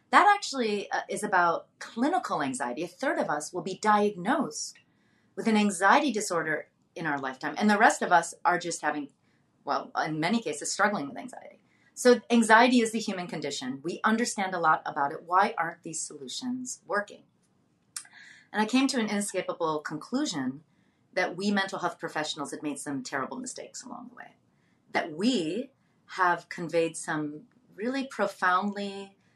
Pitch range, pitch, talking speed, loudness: 165-230 Hz, 195 Hz, 160 wpm, -28 LUFS